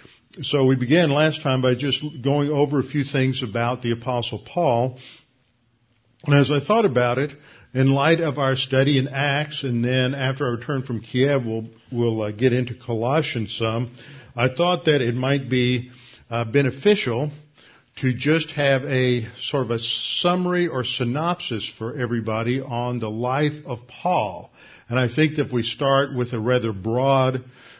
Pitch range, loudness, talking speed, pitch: 120-145 Hz, -22 LUFS, 170 wpm, 130 Hz